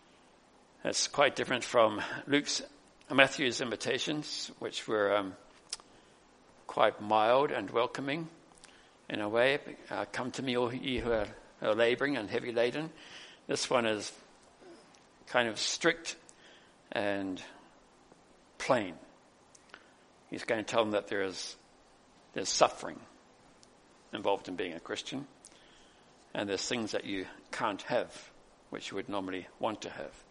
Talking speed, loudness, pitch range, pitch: 135 wpm, -32 LUFS, 105-135 Hz, 120 Hz